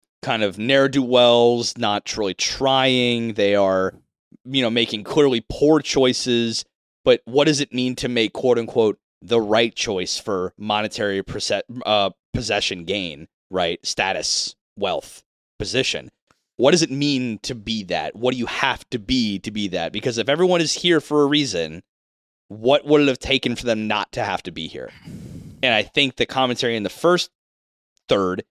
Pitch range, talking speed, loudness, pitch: 105-135 Hz, 180 wpm, -20 LUFS, 120 Hz